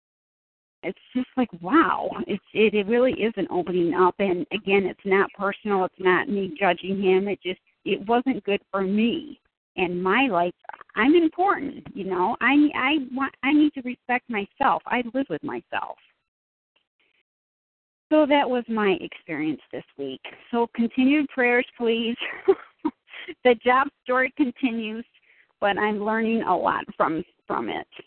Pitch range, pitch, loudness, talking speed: 195-270 Hz, 230 Hz, -23 LUFS, 150 wpm